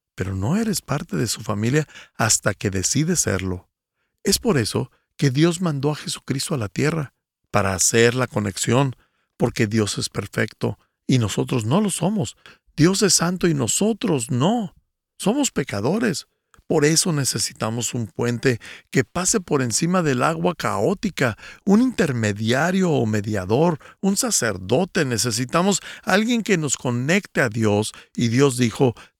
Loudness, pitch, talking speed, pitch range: -21 LUFS, 135 Hz, 145 wpm, 115-180 Hz